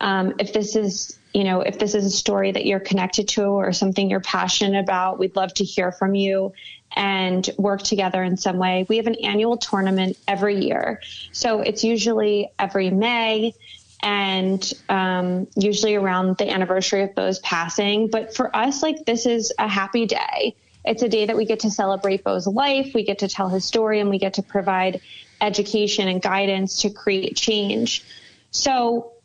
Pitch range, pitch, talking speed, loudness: 190-220 Hz, 200 Hz, 185 wpm, -21 LUFS